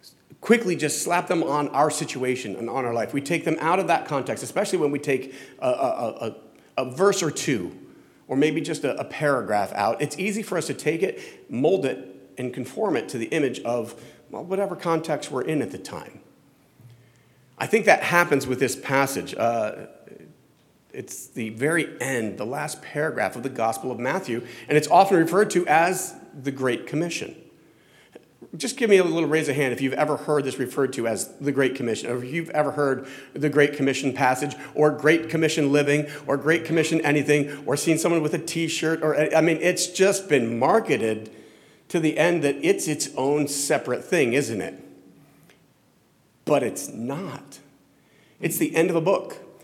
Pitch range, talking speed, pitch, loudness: 130-165 Hz, 190 wpm, 145 Hz, -23 LUFS